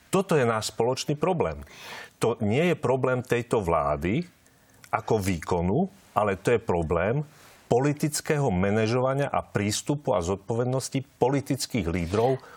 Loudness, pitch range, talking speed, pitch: -26 LUFS, 110-145 Hz, 120 wpm, 130 Hz